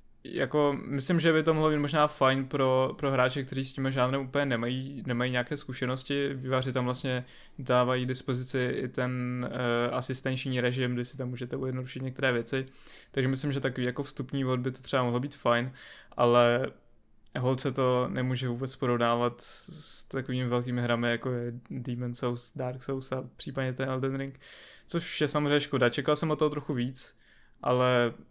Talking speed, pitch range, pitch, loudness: 175 wpm, 125-135 Hz, 130 Hz, -30 LUFS